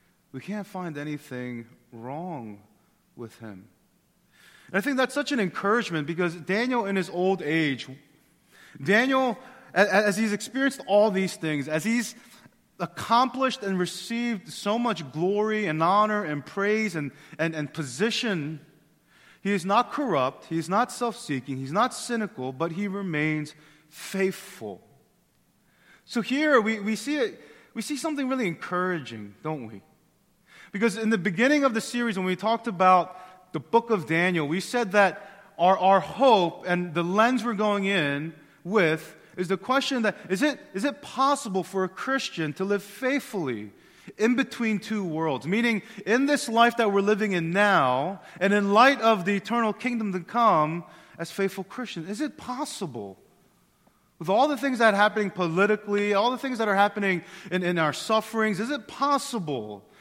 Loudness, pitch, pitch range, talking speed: -25 LUFS, 200 Hz, 165-230 Hz, 160 wpm